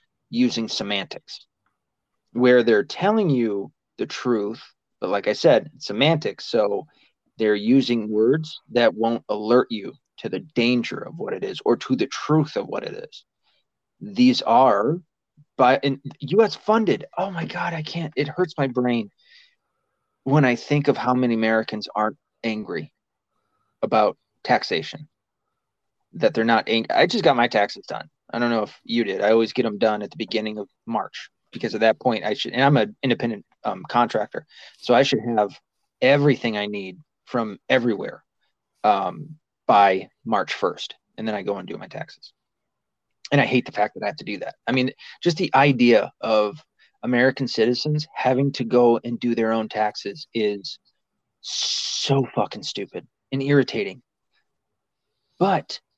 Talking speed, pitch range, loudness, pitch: 165 wpm, 110-145 Hz, -22 LUFS, 125 Hz